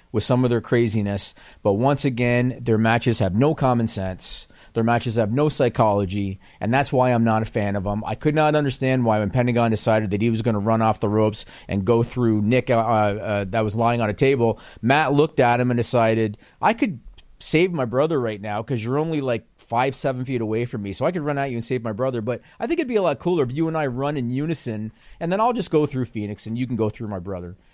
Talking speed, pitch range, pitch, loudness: 255 wpm, 110-135 Hz, 120 Hz, -22 LUFS